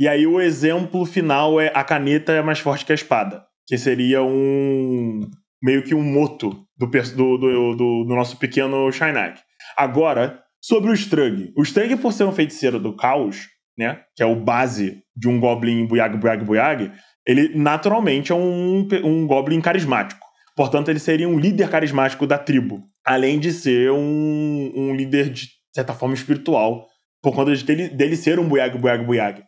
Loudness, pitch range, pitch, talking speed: -19 LUFS, 130-160 Hz, 140 Hz, 175 wpm